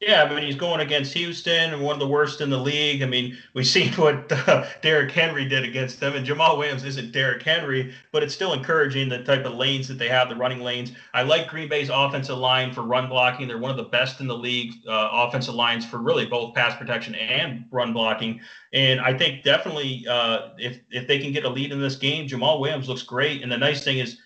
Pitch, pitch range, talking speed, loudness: 130 Hz, 125-145 Hz, 240 wpm, -22 LUFS